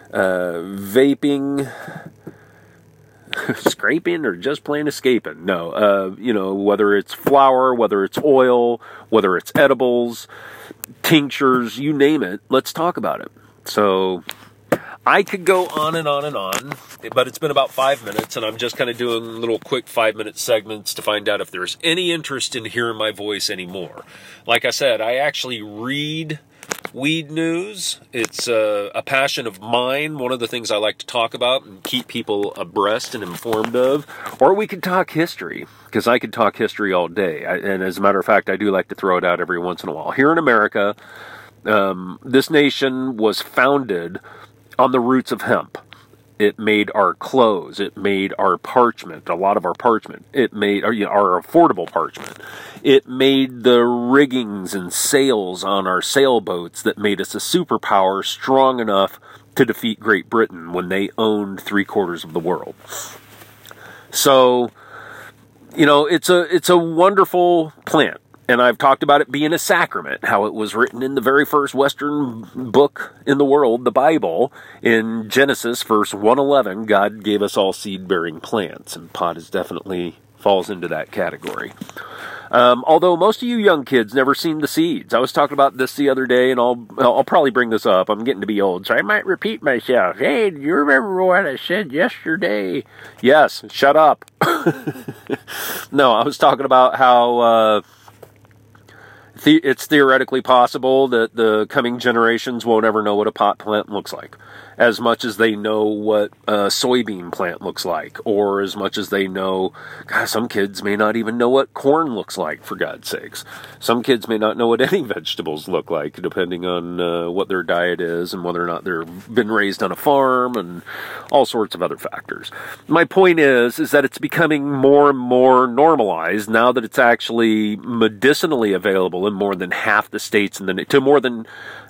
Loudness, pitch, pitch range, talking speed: -17 LUFS, 120 Hz, 105-140 Hz, 180 wpm